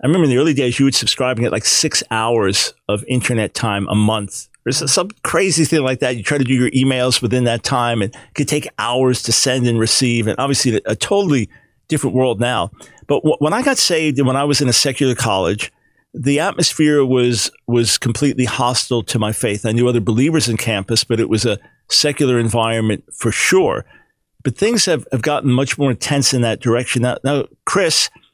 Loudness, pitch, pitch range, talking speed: -16 LUFS, 125 Hz, 115-140 Hz, 210 wpm